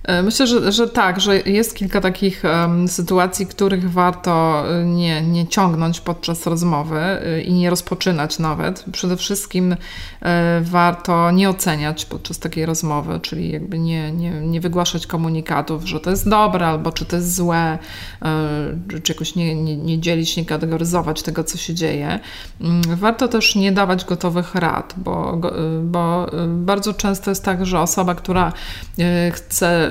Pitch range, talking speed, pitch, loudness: 165-185 Hz, 145 wpm, 175 Hz, -18 LUFS